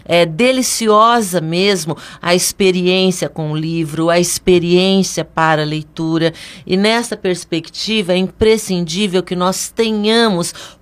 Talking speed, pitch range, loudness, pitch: 115 wpm, 165-205 Hz, -15 LUFS, 180 Hz